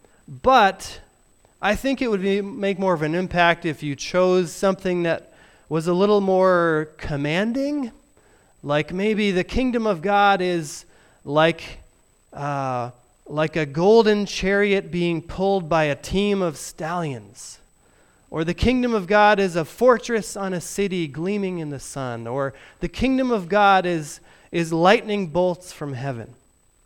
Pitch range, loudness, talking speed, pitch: 155-200 Hz, -21 LUFS, 150 wpm, 180 Hz